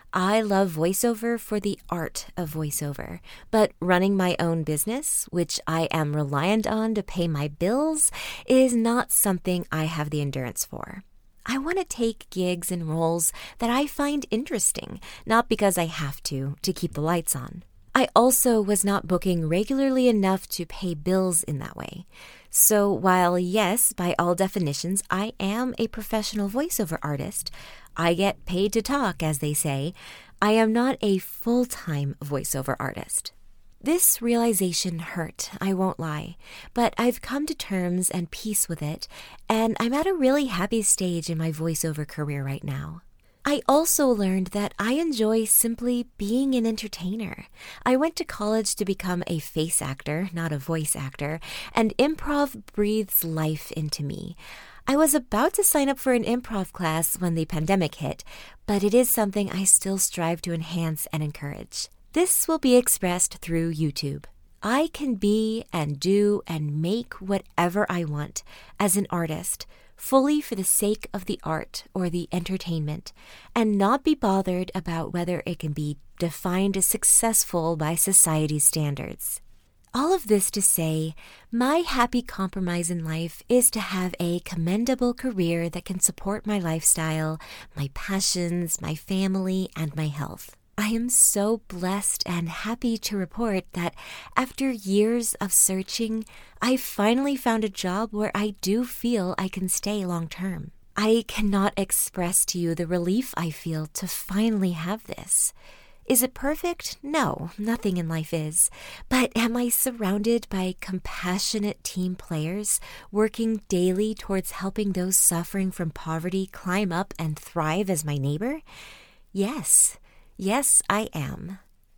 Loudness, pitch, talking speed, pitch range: -24 LUFS, 190 Hz, 160 wpm, 165-225 Hz